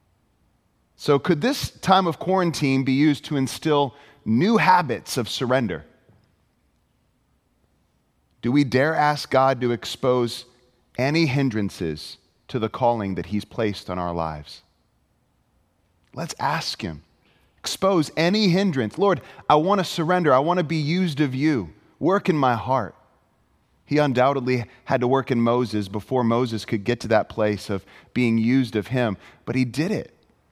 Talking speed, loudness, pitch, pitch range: 150 wpm, -22 LUFS, 130 Hz, 115-150 Hz